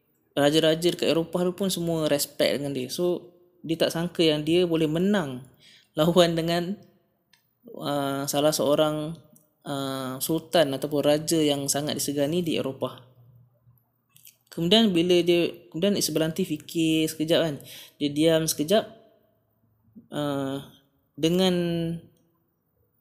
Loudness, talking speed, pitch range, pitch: -25 LUFS, 110 wpm, 140-175 Hz, 155 Hz